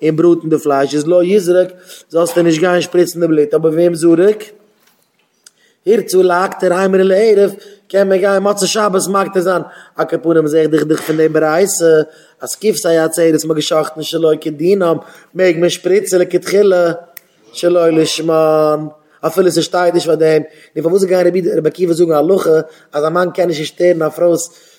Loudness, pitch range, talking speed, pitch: -13 LUFS, 160-185 Hz, 190 wpm, 170 Hz